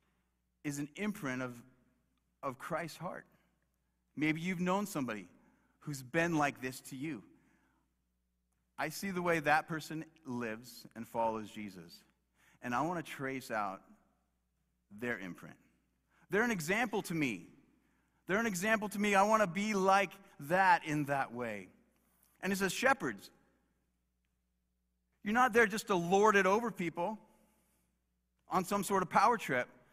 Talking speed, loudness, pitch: 140 wpm, -34 LUFS, 150 Hz